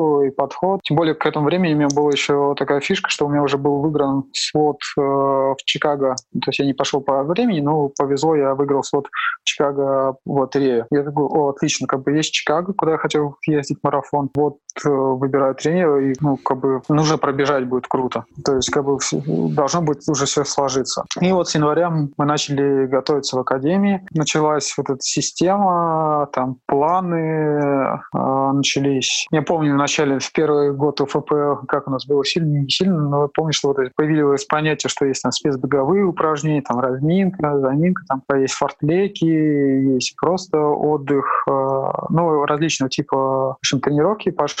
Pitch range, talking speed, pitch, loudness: 135-155 Hz, 180 wpm, 145 Hz, -19 LUFS